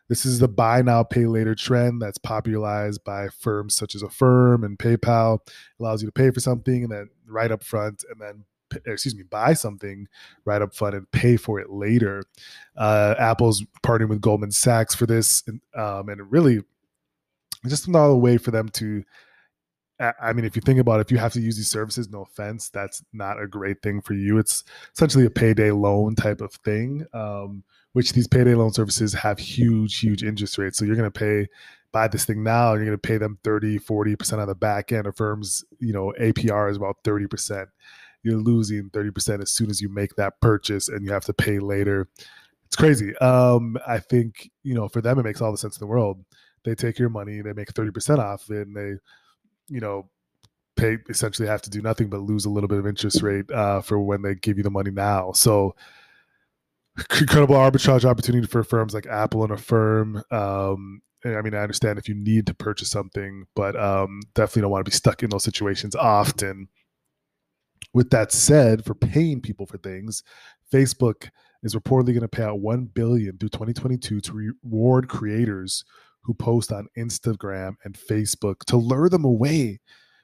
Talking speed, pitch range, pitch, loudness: 200 wpm, 105-120 Hz, 110 Hz, -22 LUFS